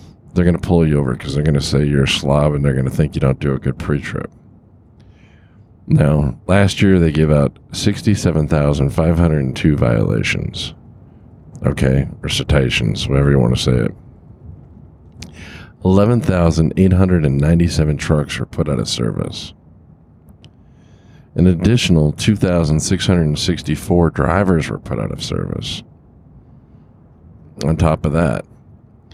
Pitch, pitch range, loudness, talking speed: 80 Hz, 75-95 Hz, -16 LUFS, 160 wpm